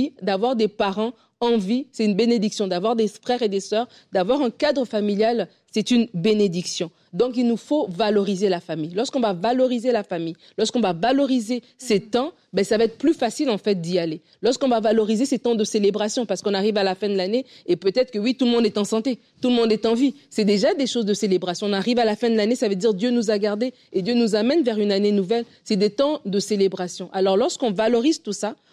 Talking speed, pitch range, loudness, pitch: 245 wpm, 205-245 Hz, -22 LUFS, 220 Hz